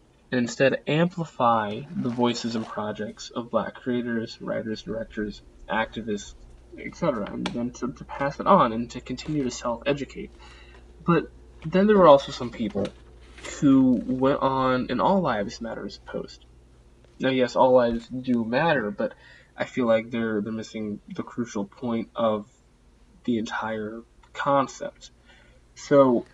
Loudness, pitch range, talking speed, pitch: -25 LUFS, 105-130 Hz, 145 wpm, 120 Hz